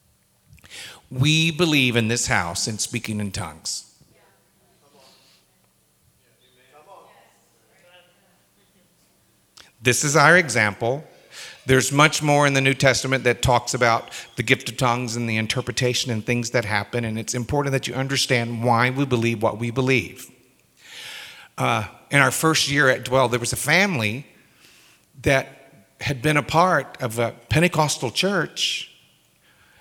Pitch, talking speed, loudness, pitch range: 125 Hz, 135 wpm, -20 LUFS, 115-140 Hz